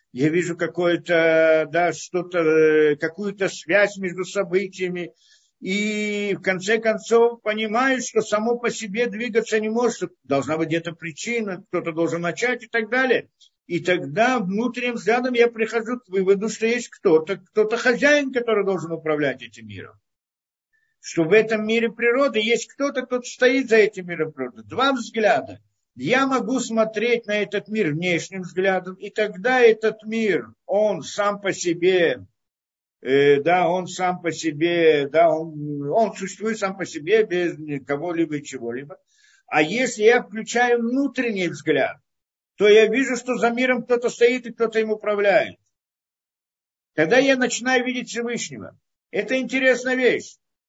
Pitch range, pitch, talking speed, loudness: 170-235 Hz, 205 Hz, 145 wpm, -21 LUFS